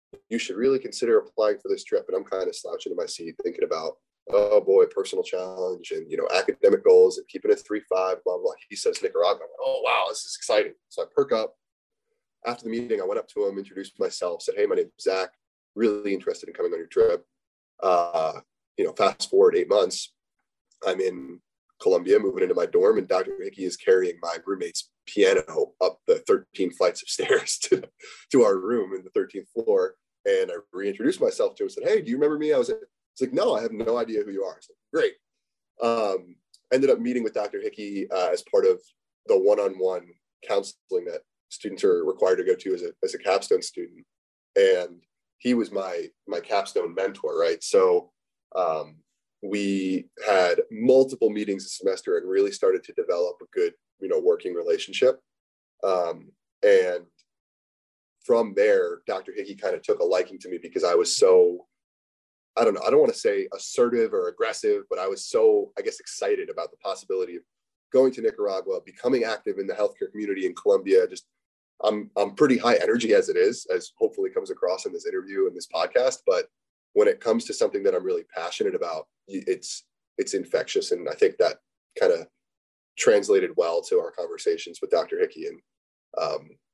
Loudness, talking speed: -25 LUFS, 200 wpm